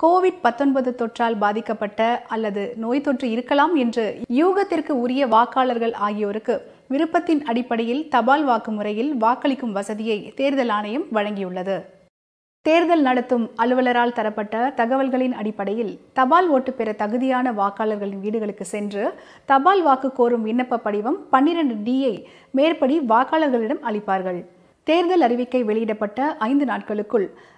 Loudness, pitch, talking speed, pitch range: -21 LUFS, 240 Hz, 110 wpm, 220-275 Hz